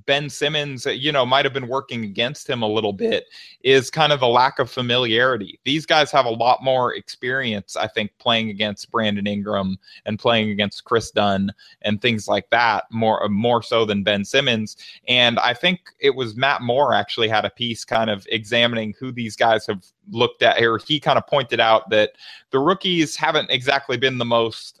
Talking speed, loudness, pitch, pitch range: 200 wpm, -20 LUFS, 120 Hz, 110-140 Hz